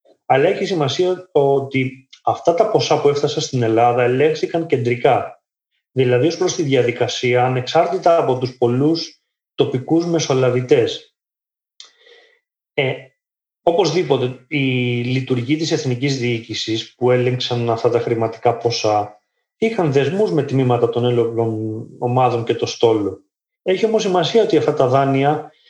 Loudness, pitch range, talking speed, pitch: -18 LUFS, 120-165 Hz, 125 wpm, 135 Hz